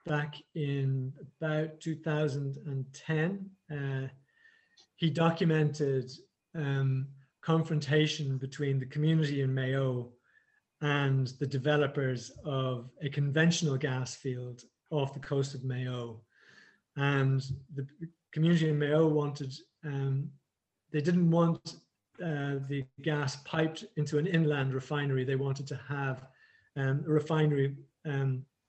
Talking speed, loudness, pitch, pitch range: 110 wpm, -32 LUFS, 145 Hz, 135-155 Hz